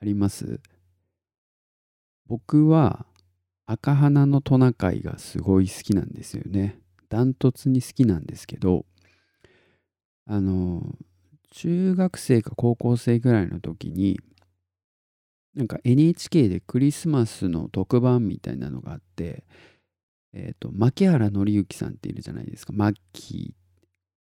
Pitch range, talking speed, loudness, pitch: 90-130 Hz, 250 characters per minute, -23 LUFS, 105 Hz